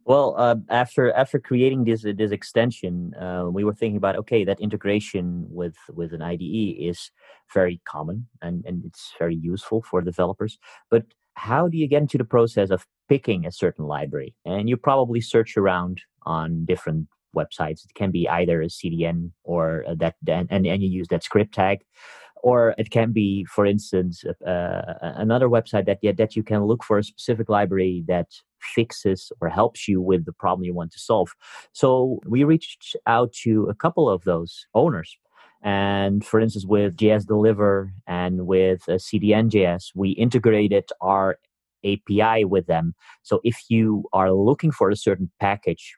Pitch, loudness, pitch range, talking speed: 100 Hz, -22 LUFS, 90-115 Hz, 170 wpm